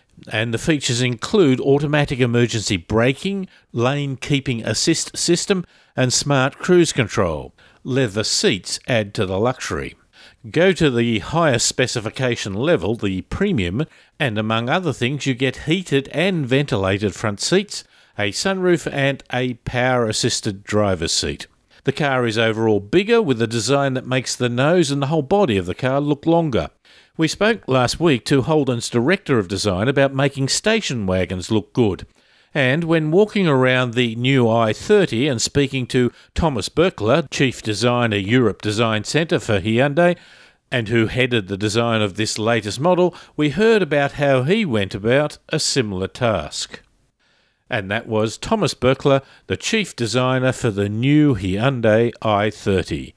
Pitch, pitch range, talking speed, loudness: 130 Hz, 110-150 Hz, 150 wpm, -19 LUFS